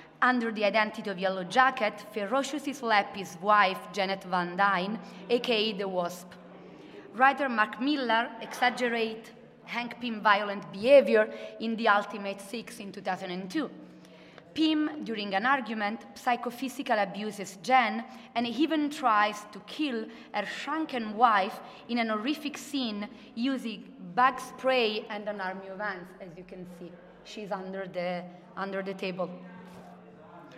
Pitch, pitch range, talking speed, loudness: 215 Hz, 195-250 Hz, 135 wpm, -29 LUFS